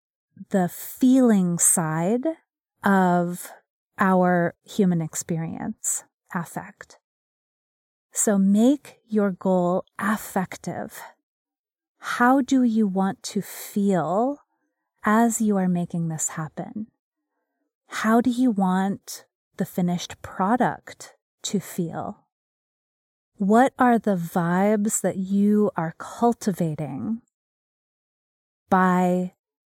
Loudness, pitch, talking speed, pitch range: -23 LUFS, 195 Hz, 85 wpm, 175-230 Hz